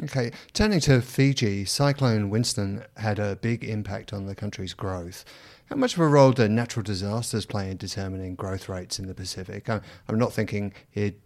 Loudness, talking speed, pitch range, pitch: -26 LUFS, 180 wpm, 100-120 Hz, 105 Hz